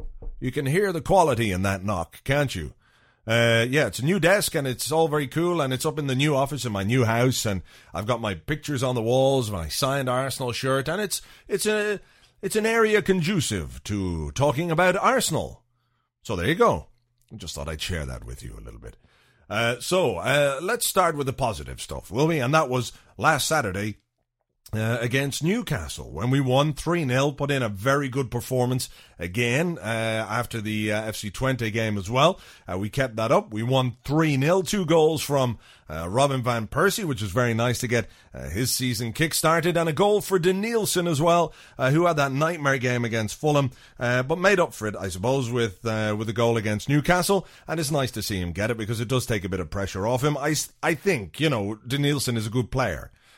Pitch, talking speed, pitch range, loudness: 130 Hz, 215 wpm, 110-155 Hz, -24 LUFS